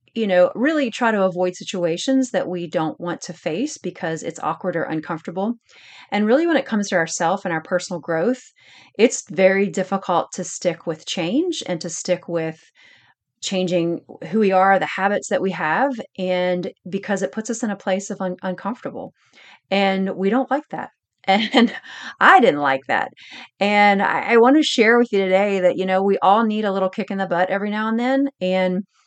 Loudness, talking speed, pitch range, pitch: -20 LUFS, 200 wpm, 180-225 Hz, 195 Hz